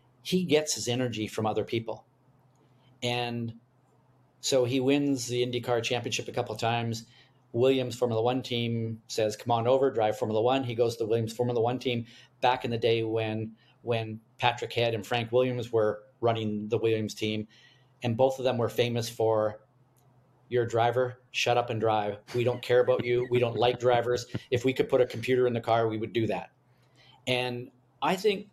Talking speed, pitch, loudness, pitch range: 195 wpm, 120 Hz, -28 LUFS, 115-130 Hz